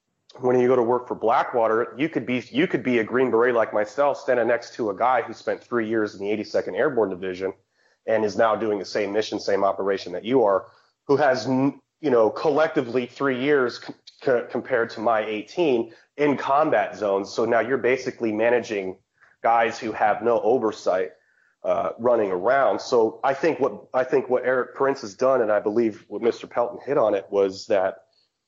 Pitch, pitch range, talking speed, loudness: 115 Hz, 105-130 Hz, 200 wpm, -23 LUFS